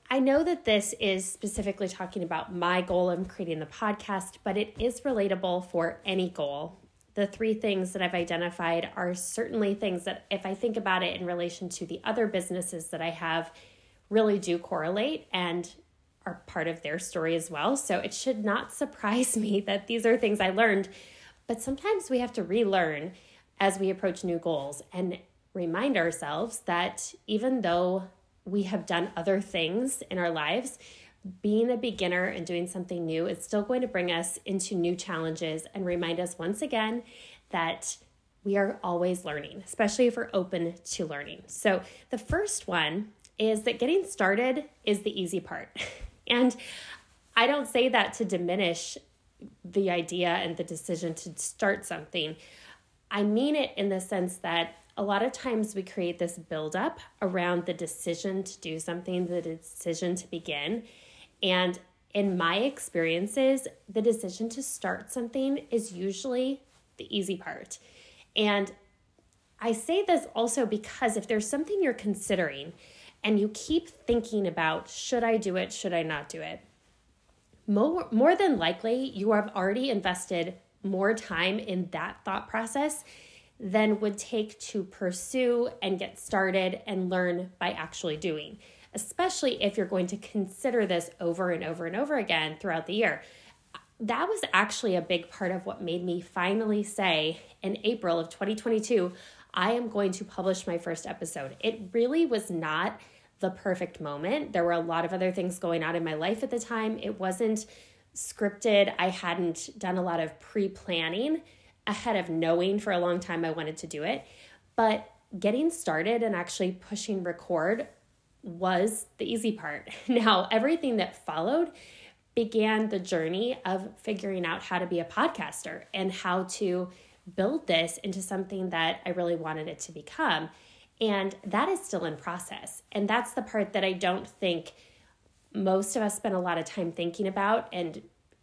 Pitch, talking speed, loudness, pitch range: 190 Hz, 170 wpm, -30 LUFS, 175-220 Hz